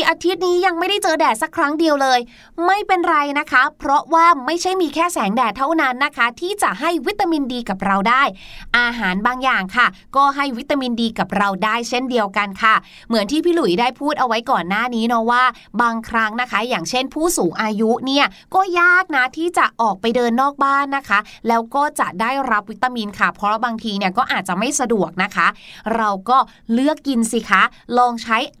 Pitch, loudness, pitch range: 250 Hz, -17 LUFS, 225-305 Hz